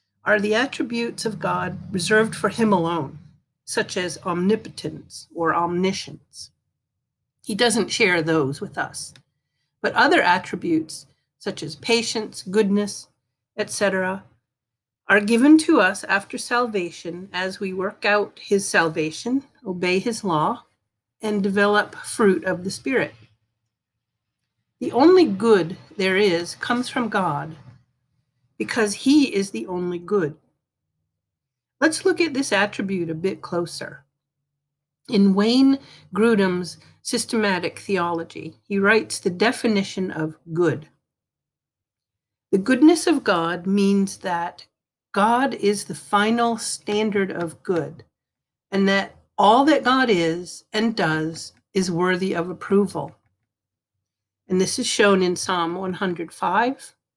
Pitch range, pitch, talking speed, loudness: 160-215 Hz, 190 Hz, 120 wpm, -21 LUFS